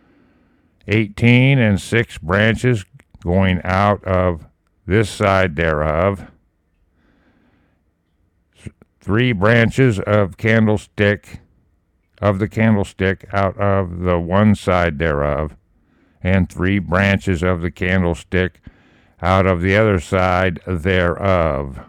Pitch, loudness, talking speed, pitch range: 95 Hz, -17 LUFS, 95 wpm, 85-105 Hz